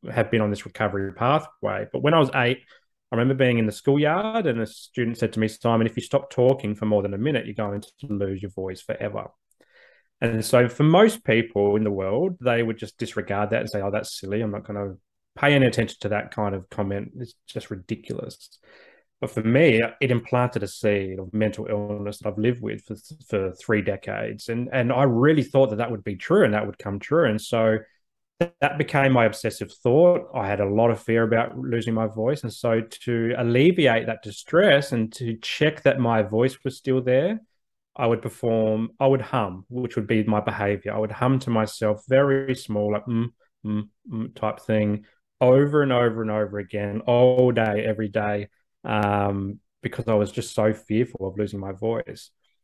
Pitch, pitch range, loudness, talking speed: 115 Hz, 105-125 Hz, -23 LUFS, 210 wpm